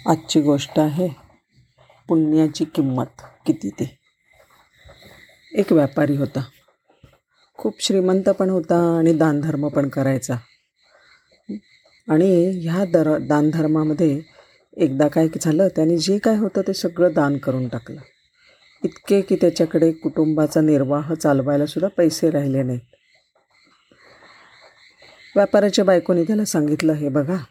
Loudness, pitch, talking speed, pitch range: -19 LUFS, 160 Hz, 110 wpm, 145-180 Hz